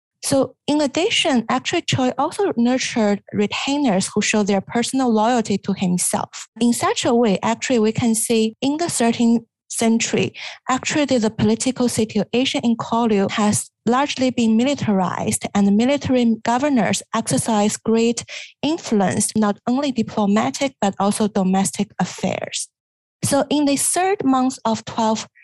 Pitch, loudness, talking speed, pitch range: 235 Hz, -19 LUFS, 140 wpm, 215-265 Hz